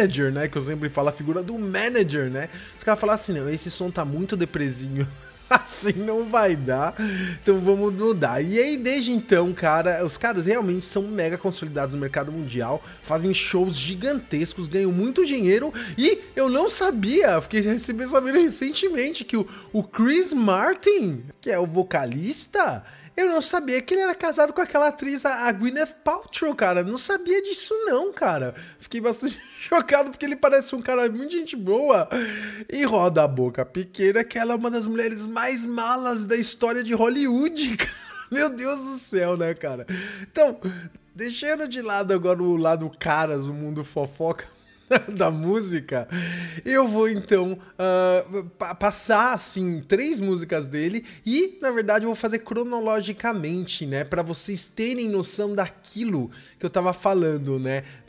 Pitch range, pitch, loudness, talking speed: 175-255 Hz, 205 Hz, -23 LUFS, 165 wpm